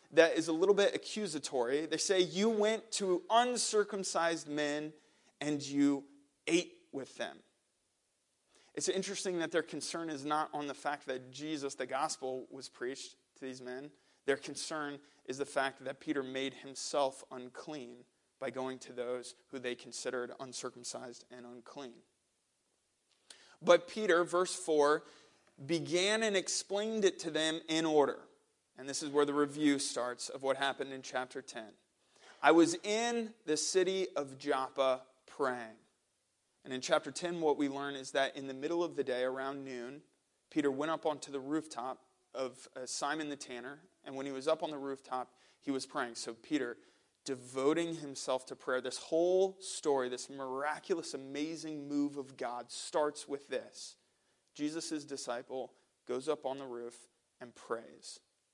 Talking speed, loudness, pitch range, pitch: 160 wpm, -36 LUFS, 130-165 Hz, 145 Hz